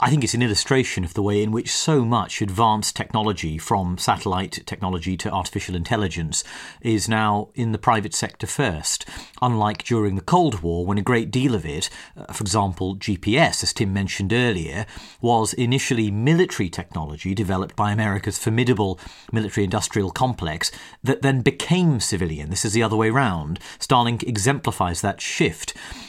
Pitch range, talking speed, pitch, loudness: 95-120 Hz, 160 wpm, 105 Hz, -22 LUFS